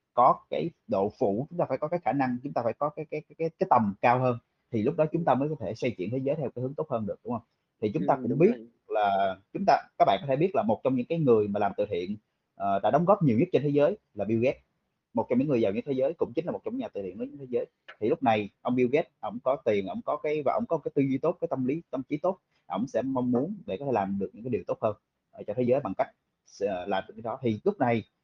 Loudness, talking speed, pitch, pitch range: -28 LUFS, 320 wpm, 130 Hz, 115-155 Hz